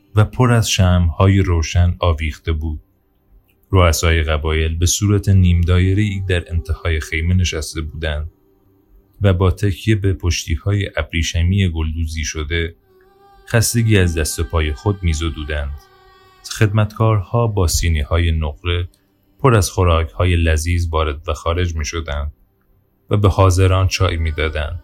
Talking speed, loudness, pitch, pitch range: 135 wpm, -17 LUFS, 90 Hz, 80-100 Hz